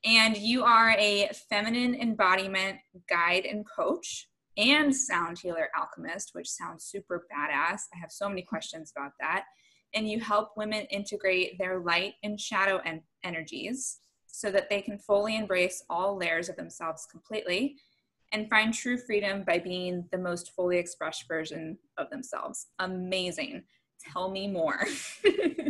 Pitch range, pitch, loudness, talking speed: 175-220 Hz, 200 Hz, -29 LUFS, 145 wpm